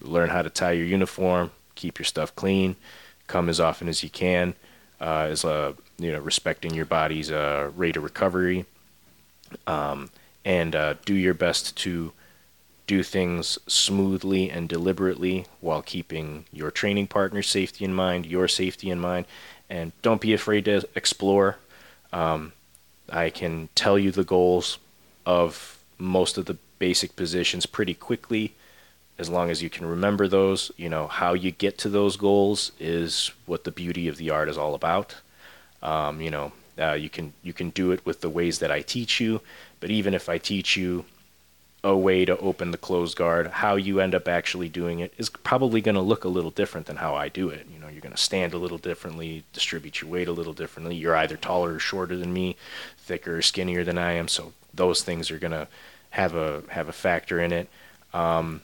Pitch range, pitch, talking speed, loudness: 80-95 Hz, 90 Hz, 195 wpm, -25 LUFS